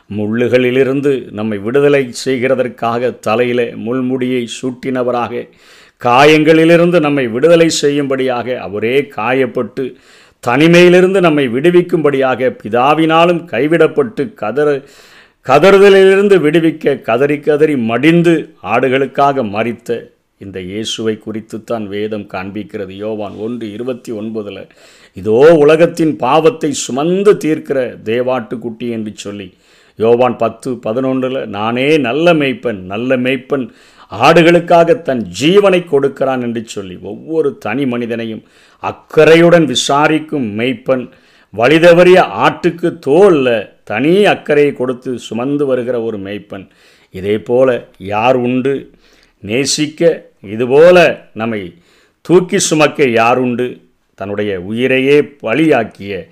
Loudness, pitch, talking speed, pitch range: -12 LUFS, 130 Hz, 95 wpm, 115-155 Hz